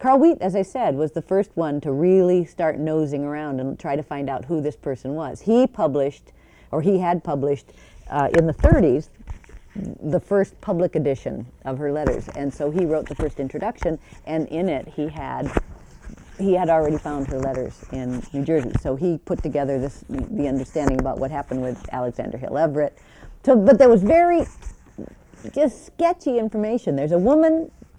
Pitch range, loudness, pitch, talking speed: 140-190 Hz, -22 LUFS, 155 Hz, 185 wpm